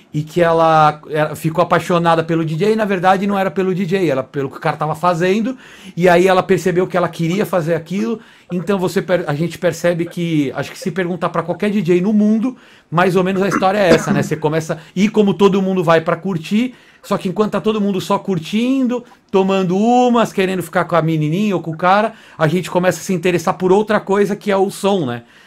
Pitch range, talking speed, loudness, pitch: 170-200 Hz, 220 wpm, -16 LUFS, 185 Hz